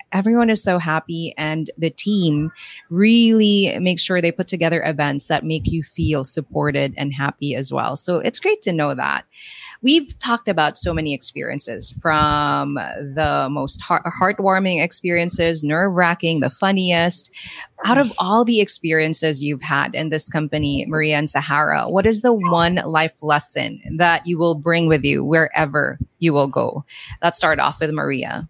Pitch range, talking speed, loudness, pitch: 150-185 Hz, 165 wpm, -18 LUFS, 165 Hz